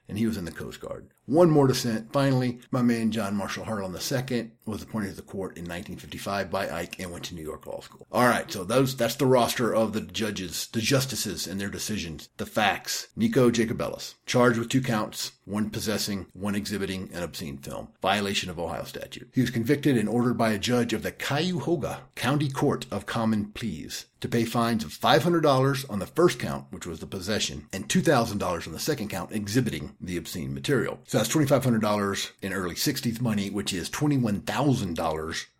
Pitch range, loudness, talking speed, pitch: 100-130 Hz, -27 LUFS, 195 wpm, 115 Hz